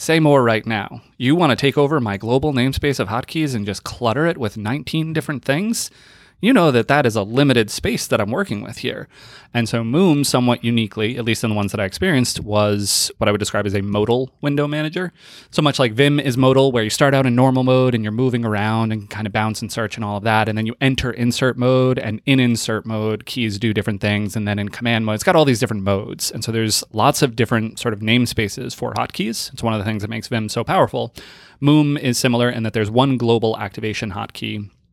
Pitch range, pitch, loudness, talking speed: 110-135 Hz, 120 Hz, -18 LUFS, 240 wpm